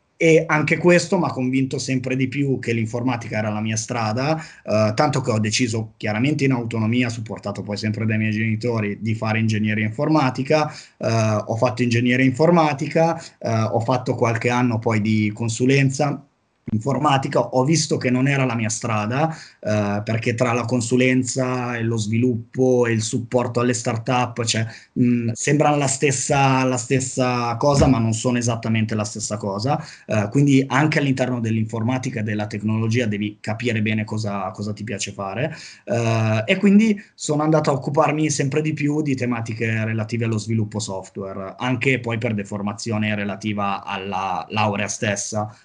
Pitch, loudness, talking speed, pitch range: 120 Hz, -21 LUFS, 160 wpm, 110-135 Hz